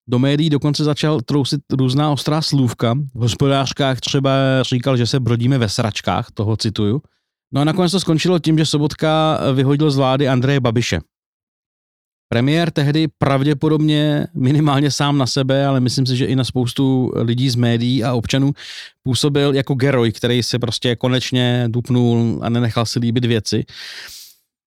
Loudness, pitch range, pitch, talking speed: -17 LUFS, 120-145 Hz, 135 Hz, 155 wpm